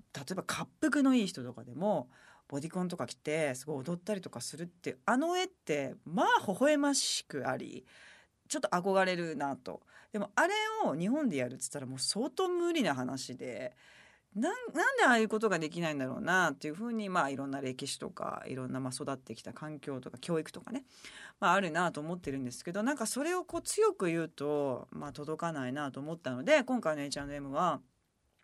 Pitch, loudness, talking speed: 170 Hz, -33 LUFS, 395 characters per minute